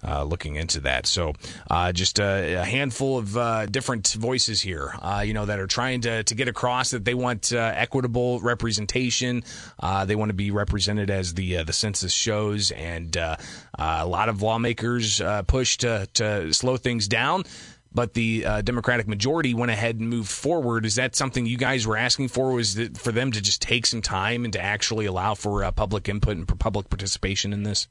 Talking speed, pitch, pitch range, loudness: 210 wpm, 110 Hz, 100-120 Hz, -24 LUFS